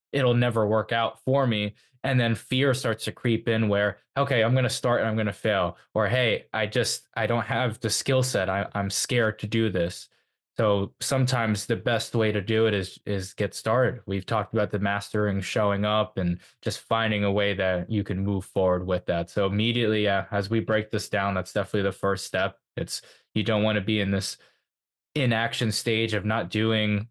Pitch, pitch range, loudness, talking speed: 110 Hz, 100-115 Hz, -26 LUFS, 215 wpm